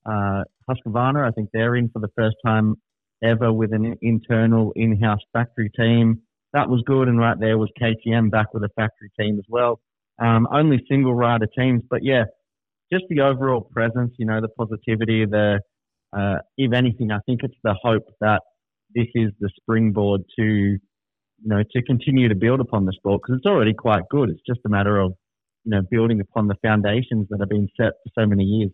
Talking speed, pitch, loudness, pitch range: 200 wpm, 110 Hz, -21 LUFS, 105-120 Hz